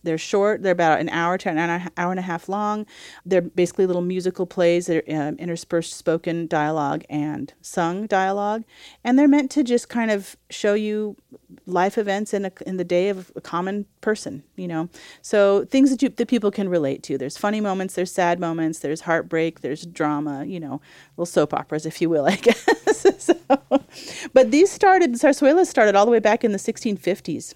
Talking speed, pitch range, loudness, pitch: 200 wpm, 170-220 Hz, -21 LUFS, 185 Hz